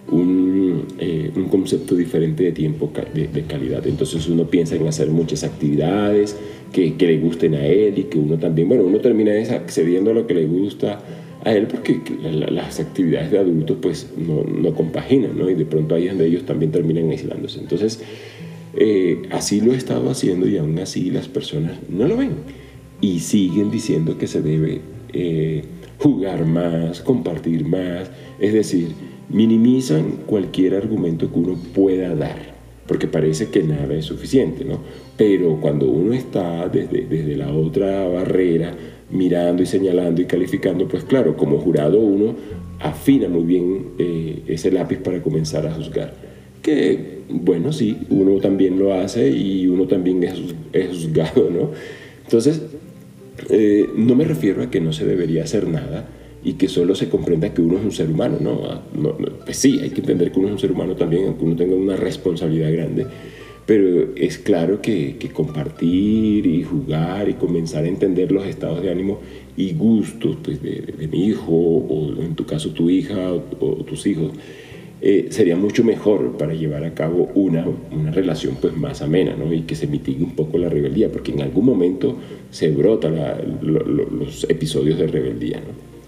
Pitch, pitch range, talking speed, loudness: 85 Hz, 80-100 Hz, 180 wpm, -19 LUFS